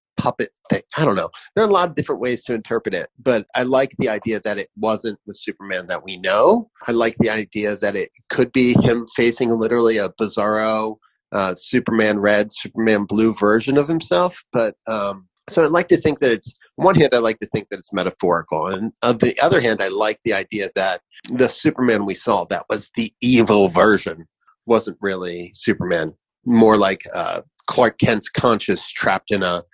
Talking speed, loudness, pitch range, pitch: 200 wpm, -19 LUFS, 105-120 Hz, 110 Hz